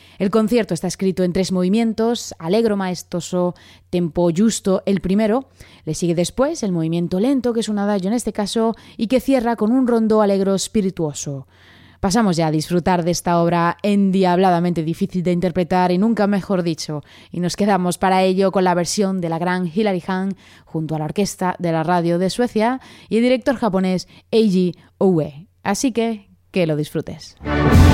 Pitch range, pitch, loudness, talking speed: 175-215 Hz, 185 Hz, -19 LUFS, 175 wpm